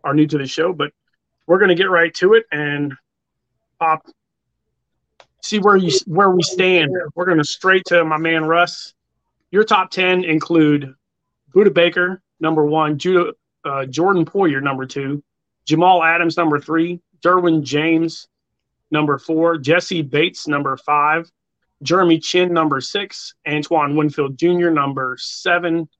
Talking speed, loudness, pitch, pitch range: 150 wpm, -17 LUFS, 165 Hz, 150-180 Hz